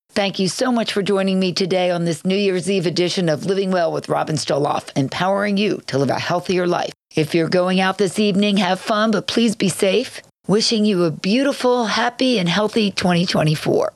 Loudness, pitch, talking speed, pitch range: -18 LUFS, 195 Hz, 200 wpm, 175-210 Hz